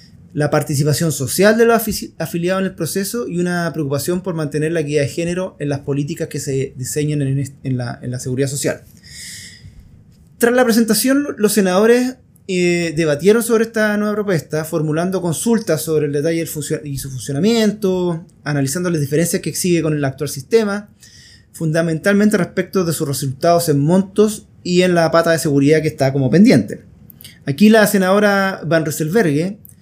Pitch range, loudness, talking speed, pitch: 150-195 Hz, -17 LUFS, 165 wpm, 165 Hz